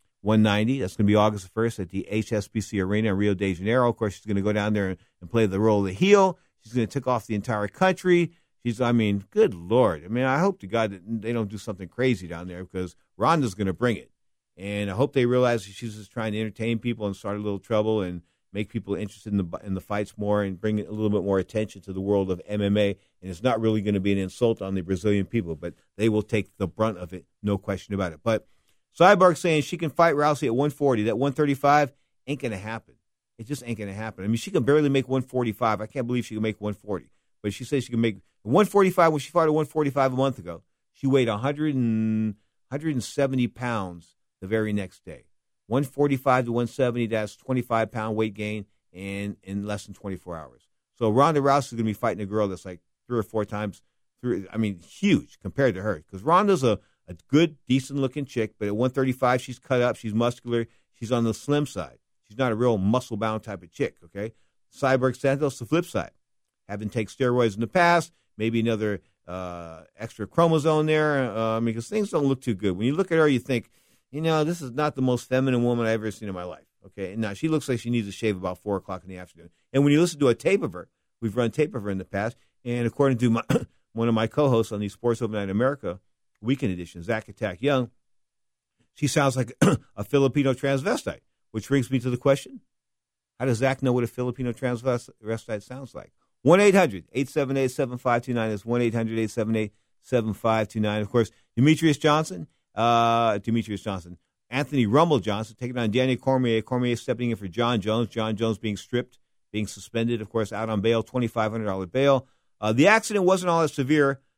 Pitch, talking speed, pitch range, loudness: 115 Hz, 230 wpm, 105-130 Hz, -25 LUFS